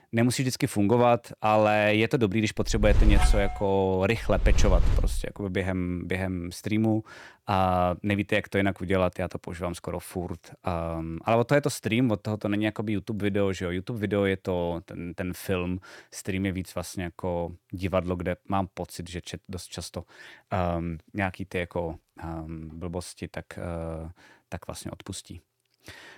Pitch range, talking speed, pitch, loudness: 90-105 Hz, 175 wpm, 95 Hz, -28 LUFS